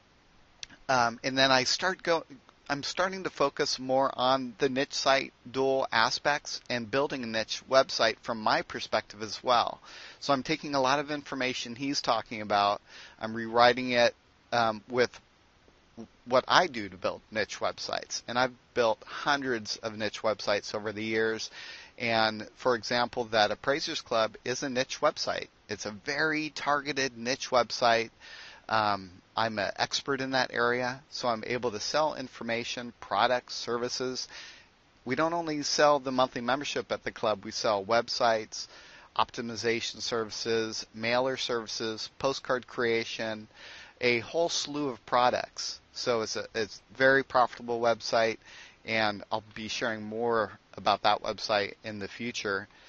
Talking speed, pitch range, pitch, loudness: 155 wpm, 110-135 Hz, 120 Hz, -29 LUFS